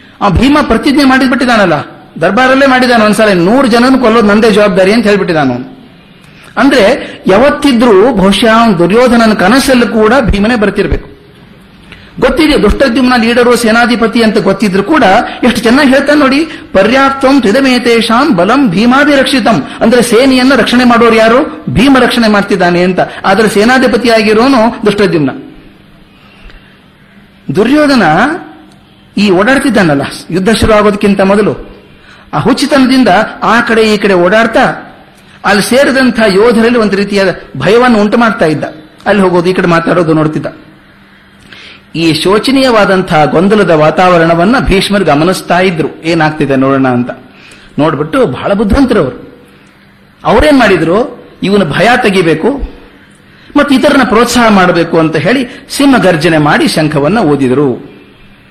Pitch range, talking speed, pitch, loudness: 185-255 Hz, 105 wpm, 220 Hz, -7 LUFS